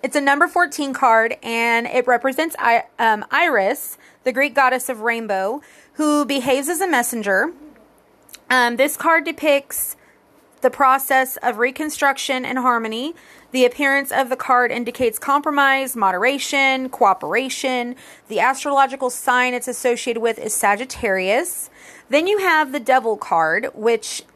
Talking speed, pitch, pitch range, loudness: 140 wpm, 260 Hz, 240-280 Hz, -18 LUFS